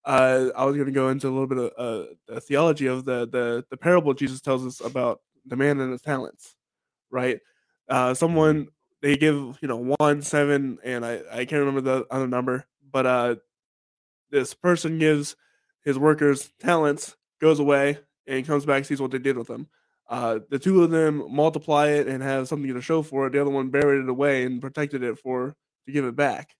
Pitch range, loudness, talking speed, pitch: 130-145 Hz, -24 LUFS, 210 wpm, 140 Hz